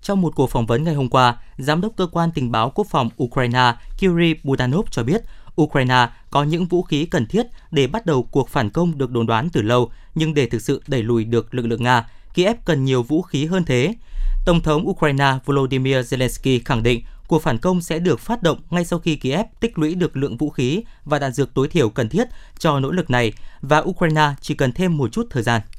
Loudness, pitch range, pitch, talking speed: -20 LUFS, 125-170 Hz, 140 Hz, 235 wpm